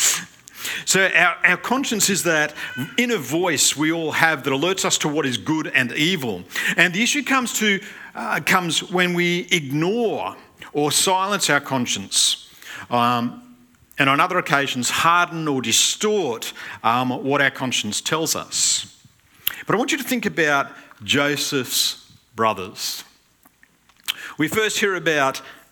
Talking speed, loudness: 140 wpm, -20 LUFS